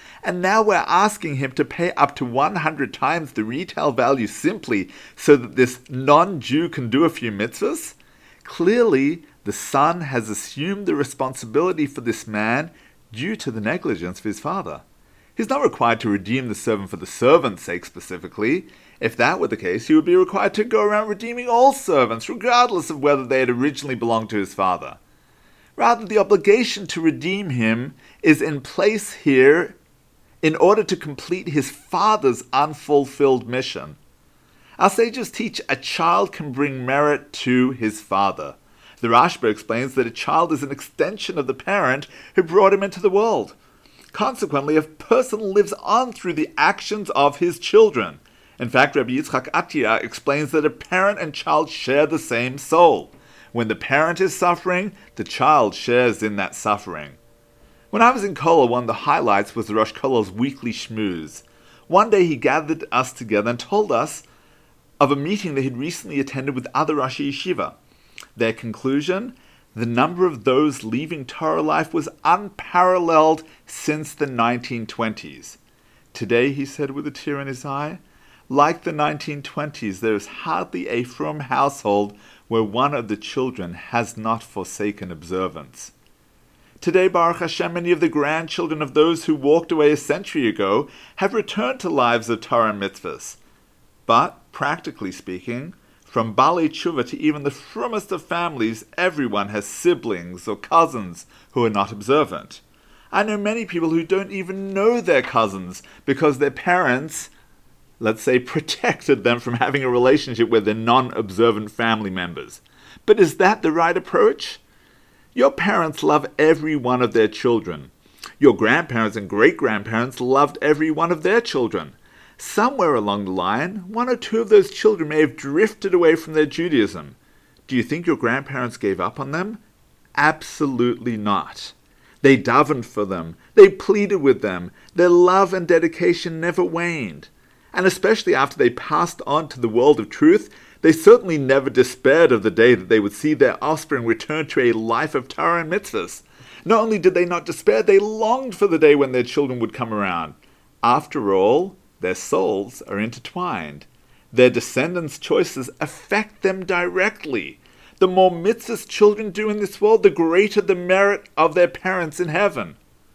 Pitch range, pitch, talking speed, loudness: 120-185 Hz, 150 Hz, 165 wpm, -19 LUFS